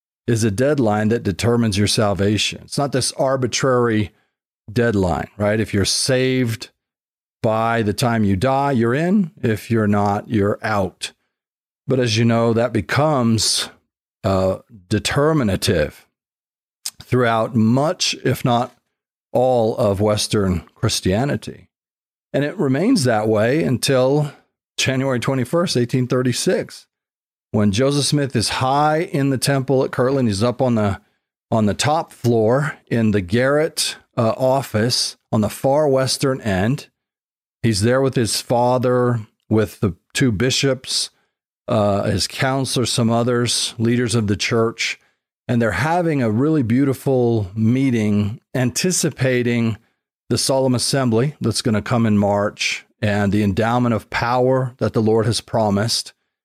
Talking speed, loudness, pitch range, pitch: 135 wpm, -19 LUFS, 110-130 Hz, 120 Hz